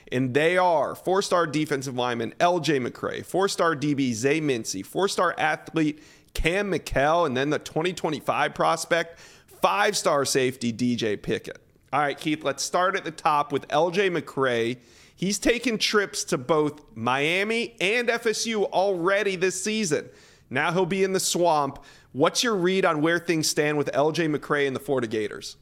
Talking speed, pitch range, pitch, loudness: 155 wpm, 140-190 Hz, 160 Hz, -24 LUFS